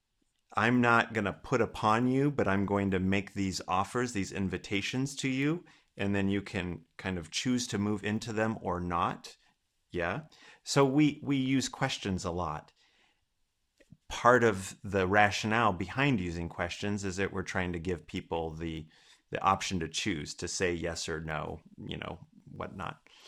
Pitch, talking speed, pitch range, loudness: 100 Hz, 170 wpm, 90-120 Hz, -31 LUFS